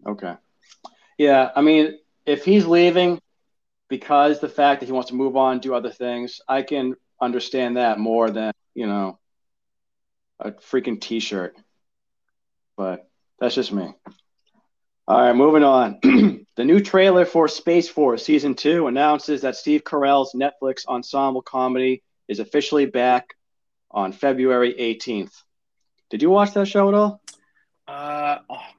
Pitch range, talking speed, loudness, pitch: 125-150 Hz, 145 wpm, -19 LUFS, 135 Hz